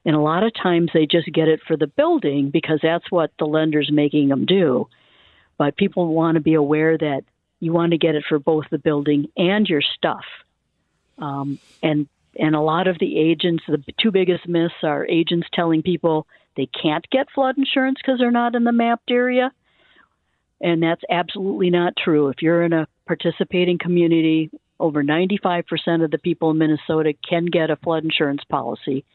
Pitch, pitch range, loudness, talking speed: 165 Hz, 155-180 Hz, -19 LUFS, 185 wpm